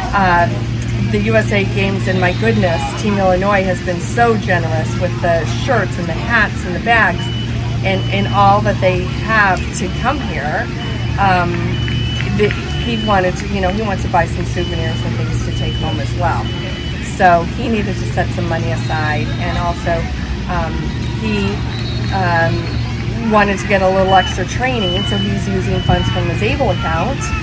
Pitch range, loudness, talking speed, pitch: 110-175 Hz, -16 LUFS, 175 wpm, 115 Hz